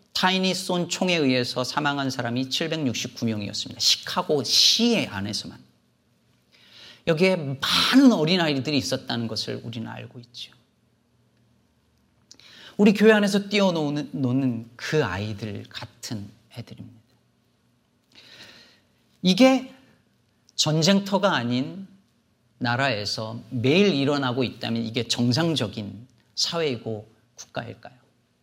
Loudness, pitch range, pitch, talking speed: -23 LUFS, 115-170 Hz, 125 Hz, 235 characters per minute